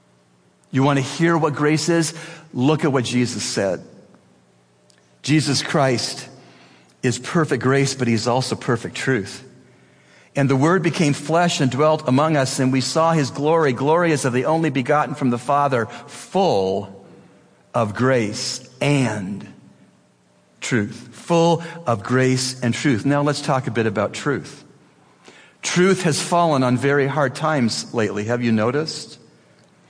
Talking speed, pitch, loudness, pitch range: 145 wpm, 130 Hz, -20 LUFS, 115-155 Hz